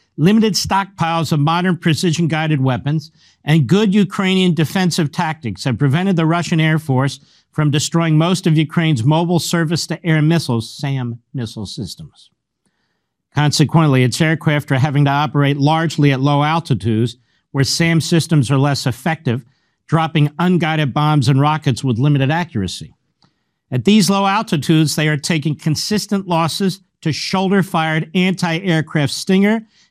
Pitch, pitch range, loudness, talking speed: 155 Hz, 140-170 Hz, -16 LUFS, 130 wpm